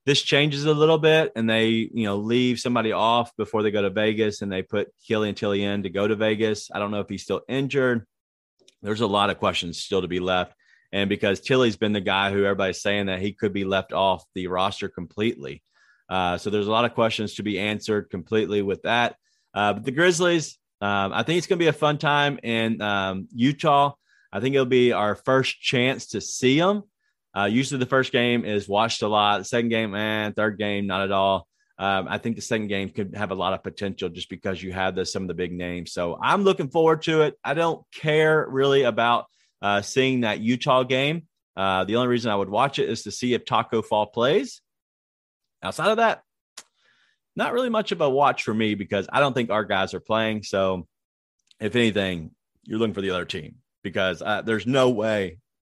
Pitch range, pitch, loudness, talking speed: 100-130 Hz, 110 Hz, -23 LUFS, 225 wpm